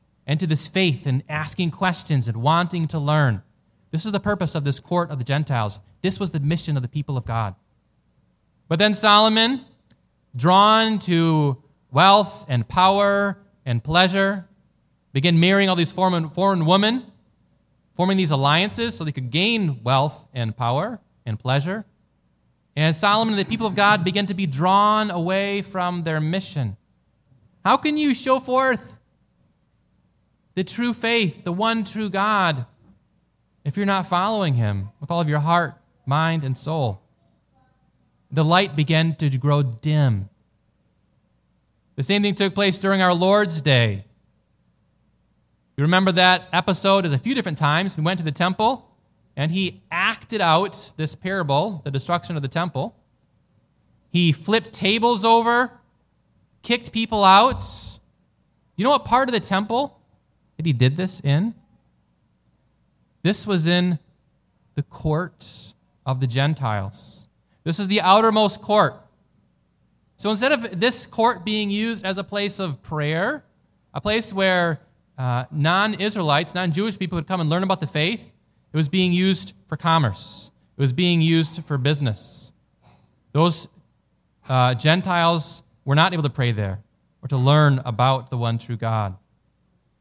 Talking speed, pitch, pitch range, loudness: 150 wpm, 170 Hz, 140-195 Hz, -21 LUFS